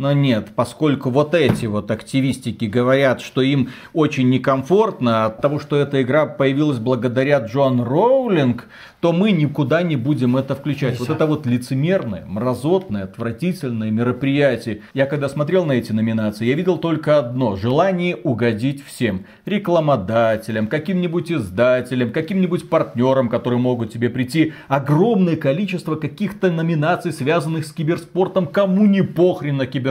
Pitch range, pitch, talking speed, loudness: 125-165 Hz, 140 Hz, 140 wpm, -19 LUFS